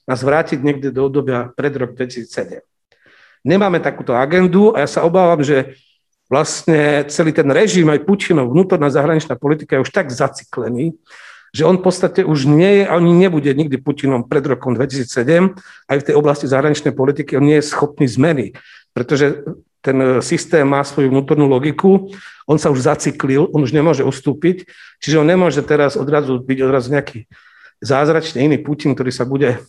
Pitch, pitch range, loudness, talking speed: 145 Hz, 135-165 Hz, -15 LUFS, 170 wpm